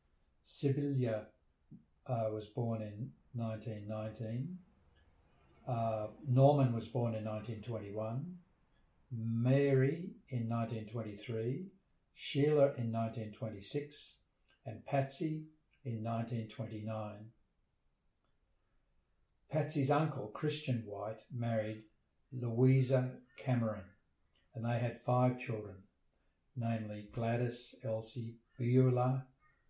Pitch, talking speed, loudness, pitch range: 115 Hz, 75 wpm, -37 LUFS, 110-130 Hz